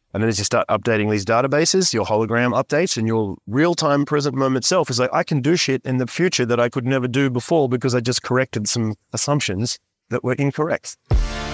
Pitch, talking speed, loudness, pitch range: 125 Hz, 220 wpm, -20 LUFS, 110-140 Hz